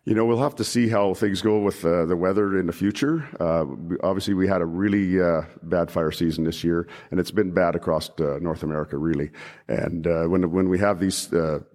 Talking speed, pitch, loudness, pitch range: 230 wpm, 95 Hz, -23 LUFS, 85-100 Hz